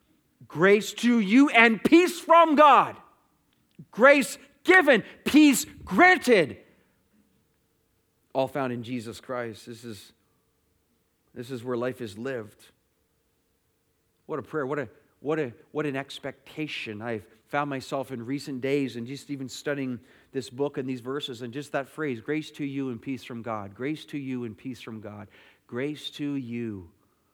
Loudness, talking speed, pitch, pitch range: -24 LUFS, 155 wpm, 135 Hz, 120-155 Hz